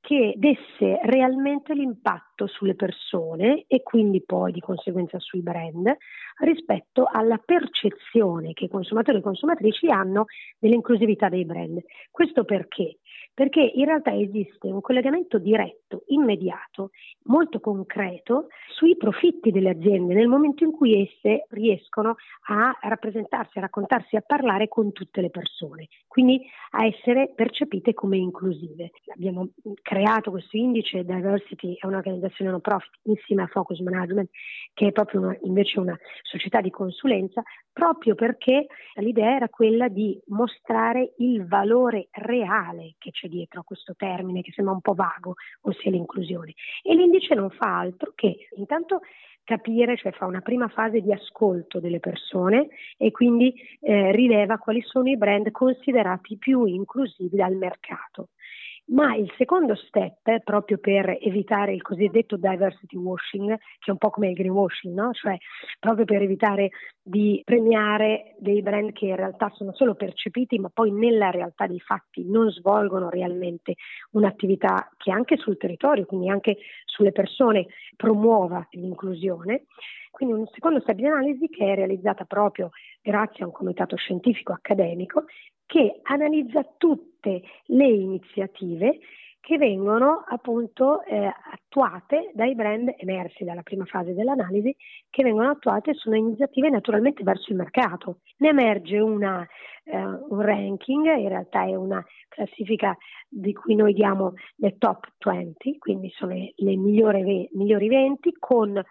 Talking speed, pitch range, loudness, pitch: 145 wpm, 190-250 Hz, -23 LUFS, 210 Hz